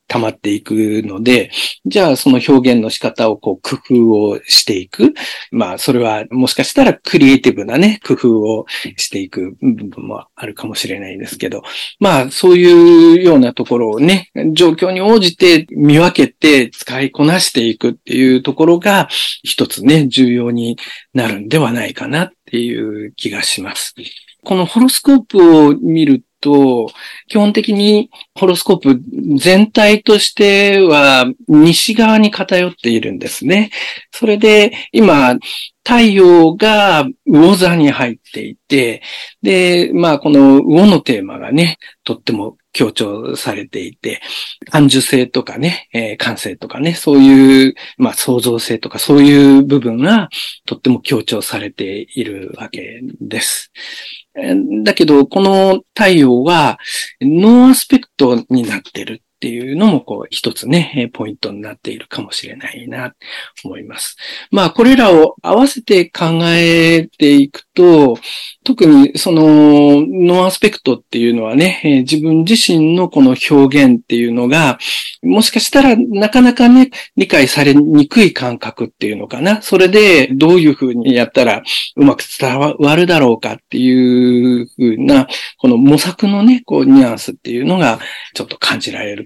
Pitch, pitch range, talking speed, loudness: 160 Hz, 130-210 Hz, 295 characters per minute, -10 LUFS